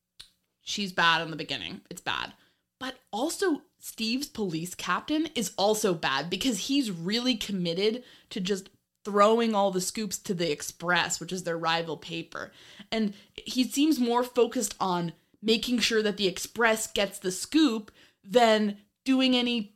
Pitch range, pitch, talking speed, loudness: 180-240 Hz, 205 Hz, 150 wpm, -27 LUFS